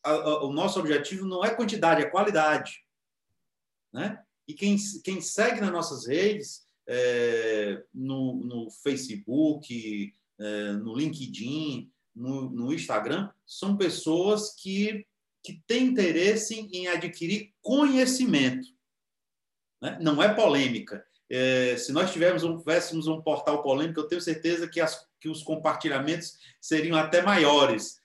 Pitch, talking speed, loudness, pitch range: 165 Hz, 125 wpm, -27 LUFS, 140-200 Hz